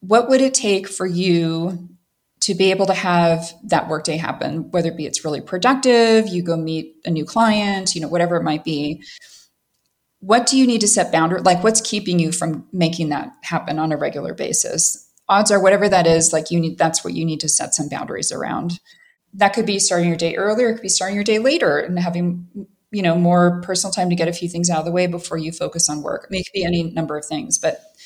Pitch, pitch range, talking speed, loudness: 175 Hz, 165-200 Hz, 240 wpm, -18 LUFS